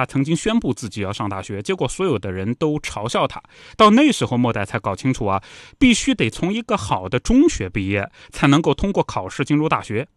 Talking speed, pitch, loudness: 325 characters per minute, 135 Hz, -19 LUFS